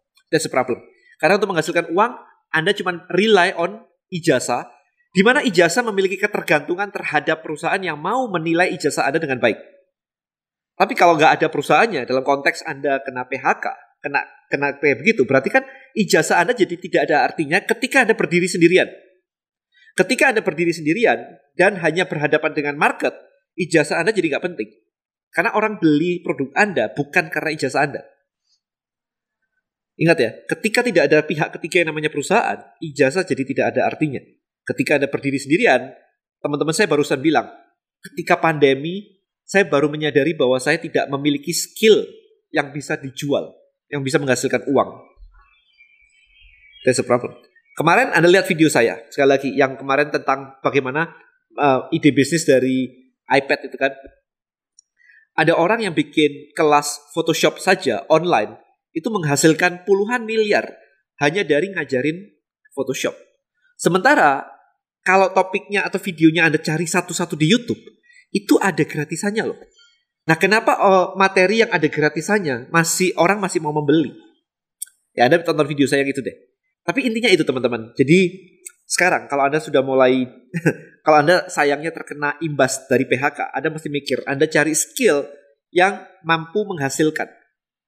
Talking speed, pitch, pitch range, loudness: 145 wpm, 170 Hz, 145-205 Hz, -18 LUFS